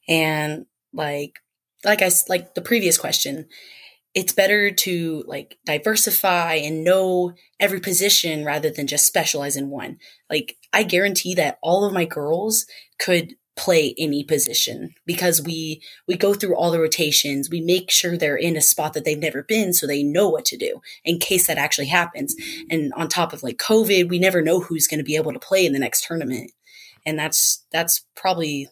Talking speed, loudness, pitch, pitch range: 185 wpm, -19 LUFS, 170 Hz, 155-185 Hz